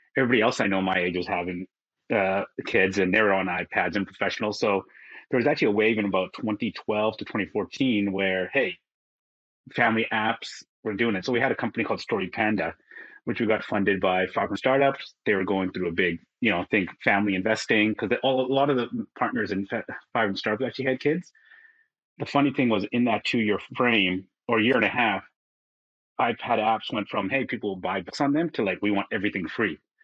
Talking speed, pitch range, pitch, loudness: 210 wpm, 95-130 Hz, 105 Hz, -25 LUFS